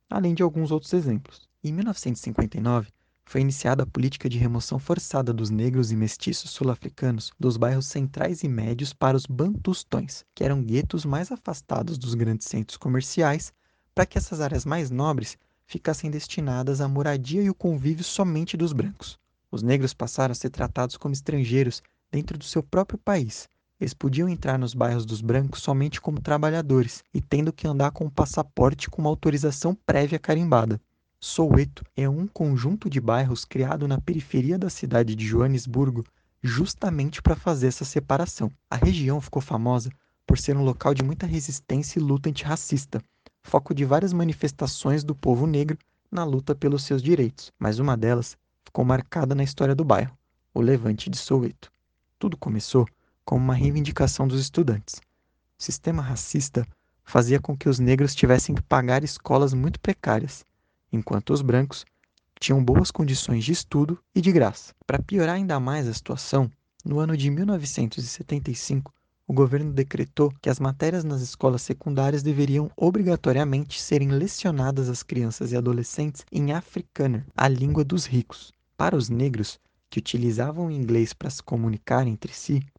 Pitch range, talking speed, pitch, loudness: 125-155 Hz, 160 wpm, 140 Hz, -25 LUFS